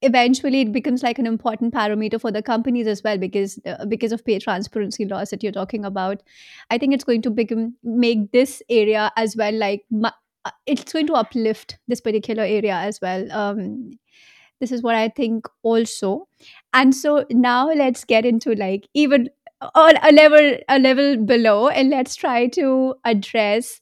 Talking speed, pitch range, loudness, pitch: 175 wpm, 215-260 Hz, -18 LUFS, 235 Hz